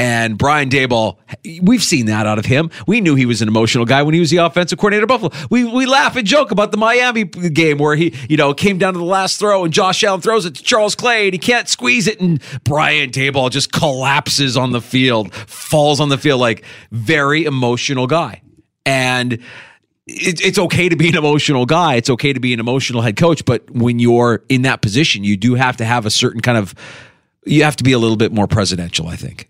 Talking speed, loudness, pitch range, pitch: 235 wpm, -14 LUFS, 120-175 Hz, 140 Hz